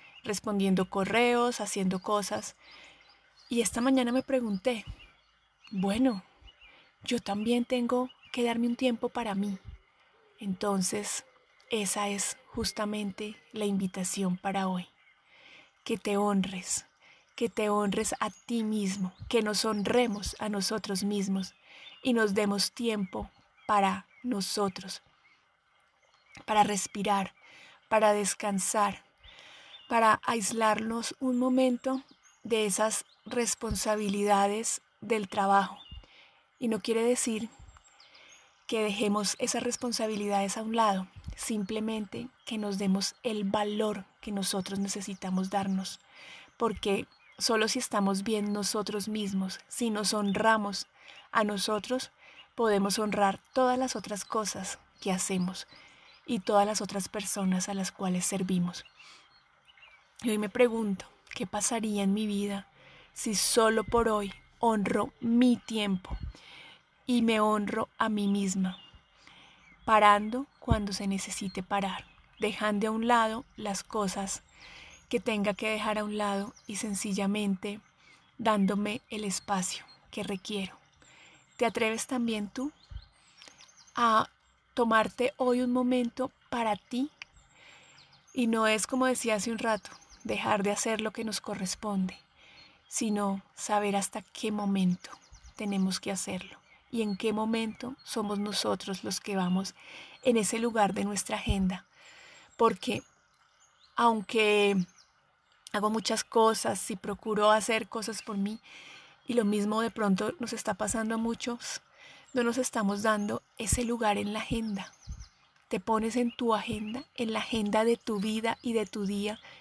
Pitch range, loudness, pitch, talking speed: 200-230 Hz, -30 LUFS, 215 Hz, 125 wpm